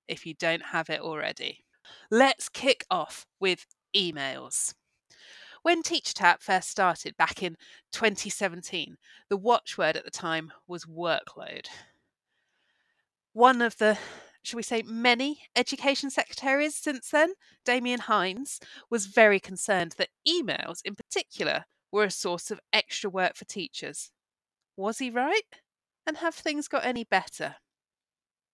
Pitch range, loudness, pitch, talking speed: 185-275 Hz, -27 LUFS, 225 Hz, 130 wpm